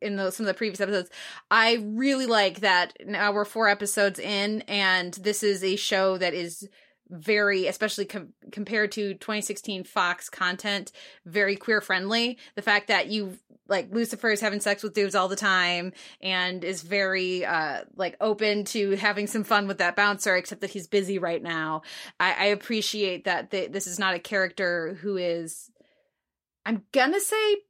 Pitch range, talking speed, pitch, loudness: 190-215 Hz, 180 wpm, 200 Hz, -25 LUFS